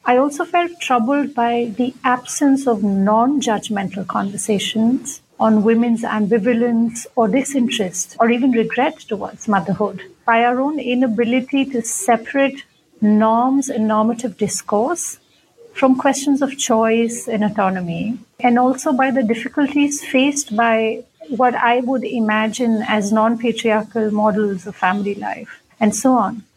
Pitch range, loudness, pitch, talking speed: 215-260 Hz, -18 LUFS, 235 Hz, 130 wpm